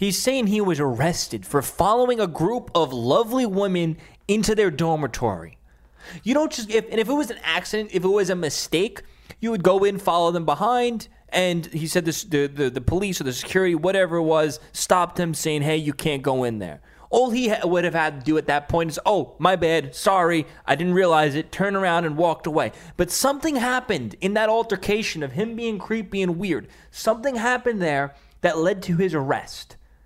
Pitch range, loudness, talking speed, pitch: 155-210 Hz, -22 LUFS, 210 wpm, 175 Hz